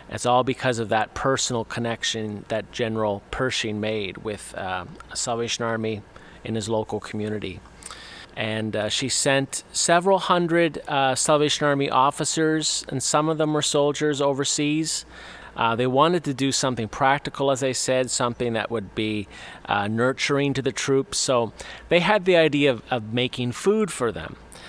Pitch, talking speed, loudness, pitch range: 130 Hz, 160 wpm, -23 LUFS, 110-145 Hz